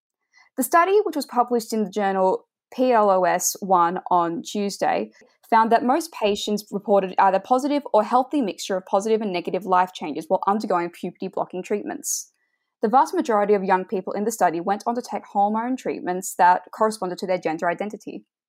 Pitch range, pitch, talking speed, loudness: 185-240 Hz, 205 Hz, 170 wpm, -22 LUFS